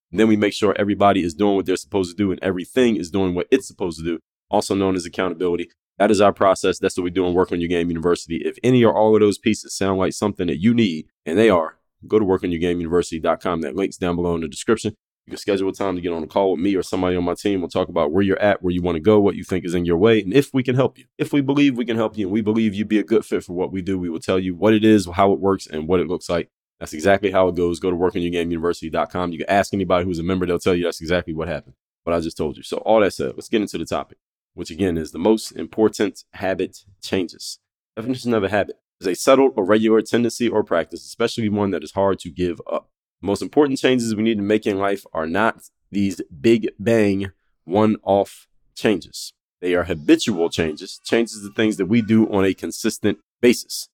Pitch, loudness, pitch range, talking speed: 95 Hz, -20 LUFS, 90-110 Hz, 265 wpm